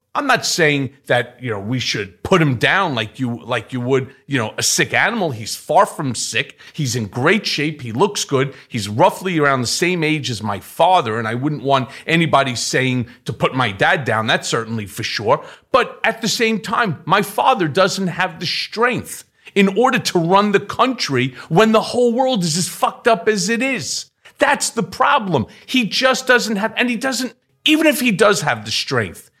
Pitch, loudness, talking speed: 170 Hz, -17 LUFS, 205 wpm